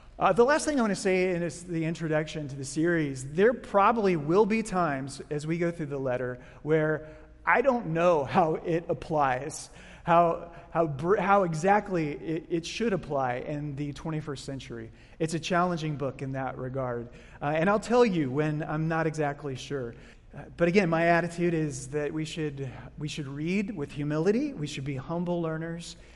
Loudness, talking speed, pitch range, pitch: -28 LUFS, 195 wpm, 145-175 Hz, 160 Hz